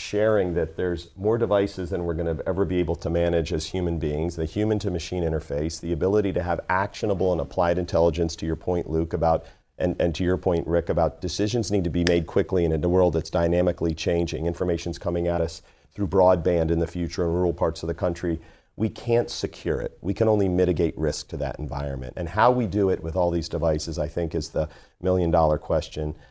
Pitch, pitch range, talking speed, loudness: 85 Hz, 80-90 Hz, 225 wpm, -25 LUFS